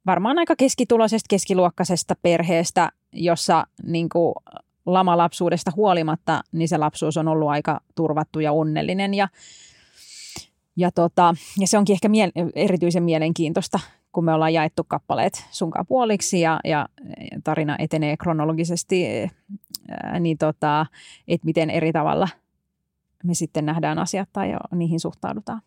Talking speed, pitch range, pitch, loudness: 130 wpm, 160-190 Hz, 170 Hz, -22 LUFS